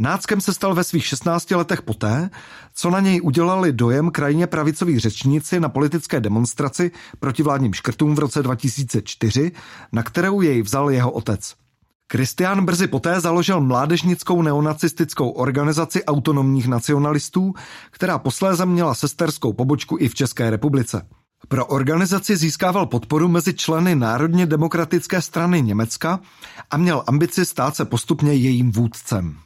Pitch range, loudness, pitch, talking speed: 130-175 Hz, -19 LUFS, 150 Hz, 135 wpm